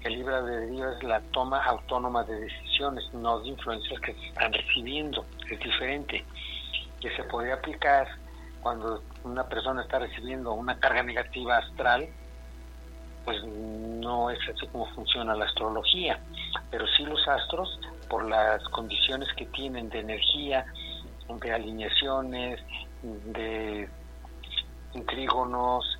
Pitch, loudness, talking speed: 115 Hz, -29 LUFS, 125 wpm